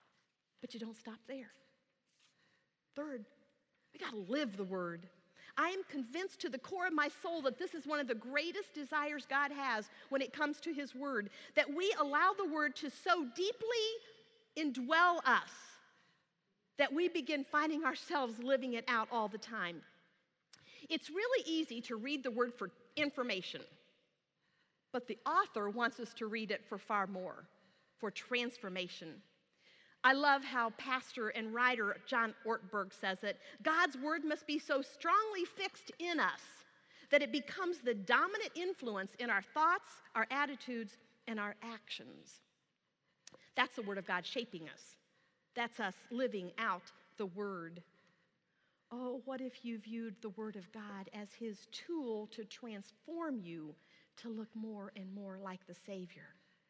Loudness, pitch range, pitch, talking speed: -38 LUFS, 210-295 Hz, 245 Hz, 155 wpm